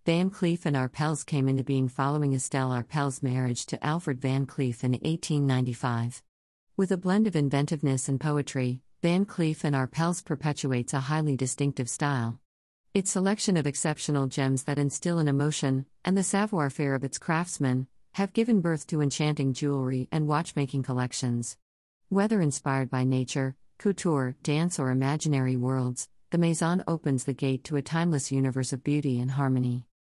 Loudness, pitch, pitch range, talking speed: -28 LUFS, 140 Hz, 130-160 Hz, 160 wpm